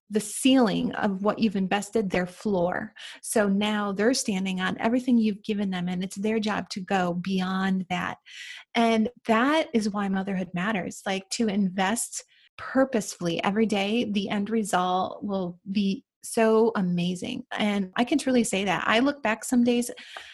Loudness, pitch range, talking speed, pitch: -26 LUFS, 190-230 Hz, 160 wpm, 210 Hz